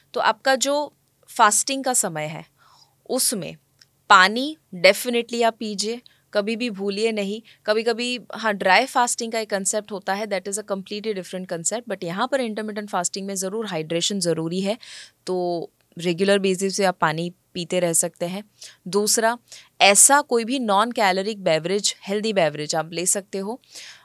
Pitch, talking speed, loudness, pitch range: 205 Hz, 160 wpm, -21 LUFS, 185-230 Hz